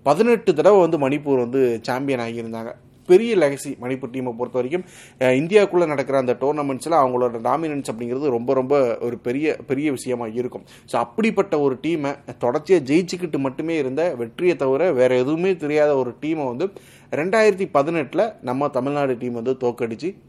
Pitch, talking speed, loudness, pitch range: 135 Hz, 150 wpm, -21 LUFS, 125-160 Hz